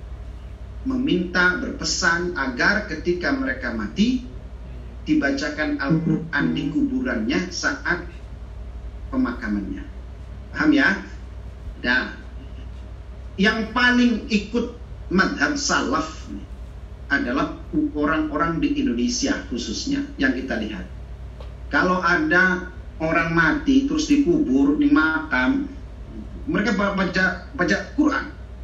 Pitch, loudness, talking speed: 165 Hz, -21 LUFS, 85 wpm